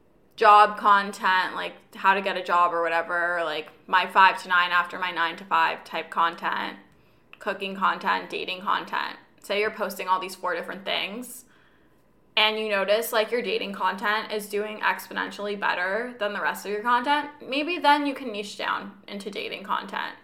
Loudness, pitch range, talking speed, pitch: -24 LUFS, 185-220 Hz, 180 wpm, 205 Hz